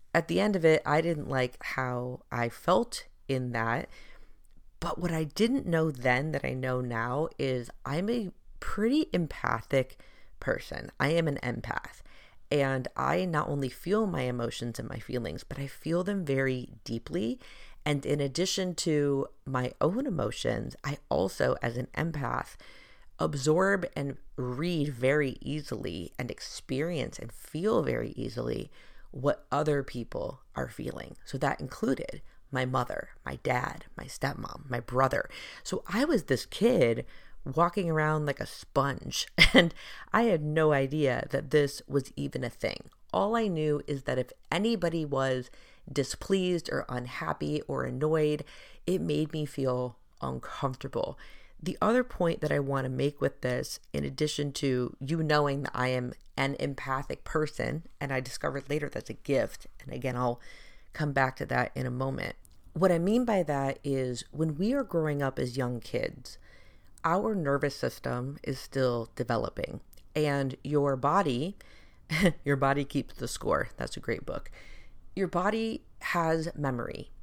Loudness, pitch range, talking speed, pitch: -31 LUFS, 130-160 Hz, 155 wpm, 140 Hz